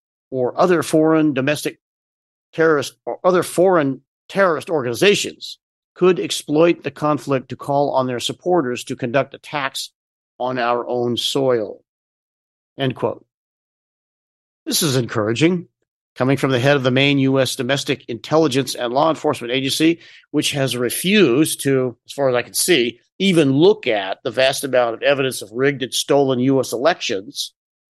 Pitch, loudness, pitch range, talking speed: 135 Hz, -18 LUFS, 125-155 Hz, 150 wpm